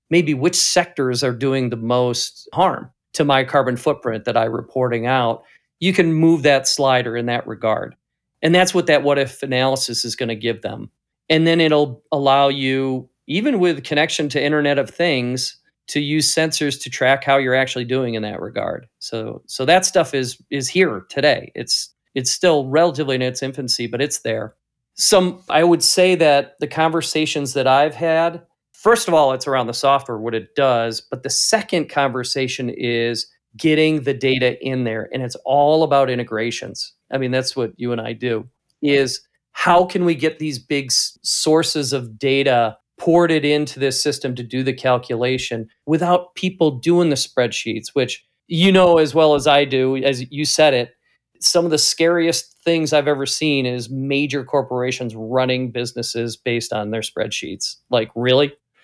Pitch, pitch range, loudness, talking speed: 135 Hz, 125-155 Hz, -18 LUFS, 175 wpm